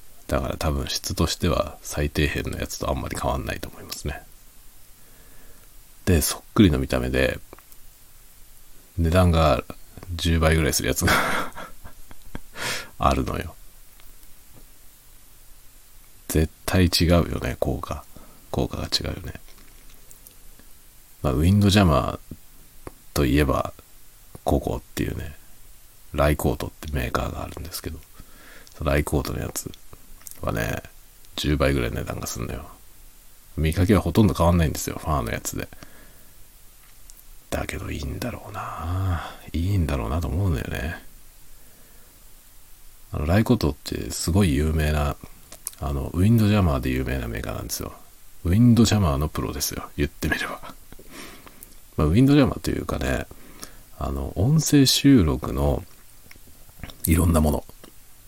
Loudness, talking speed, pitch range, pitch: -23 LUFS, 275 characters per minute, 75-100 Hz, 90 Hz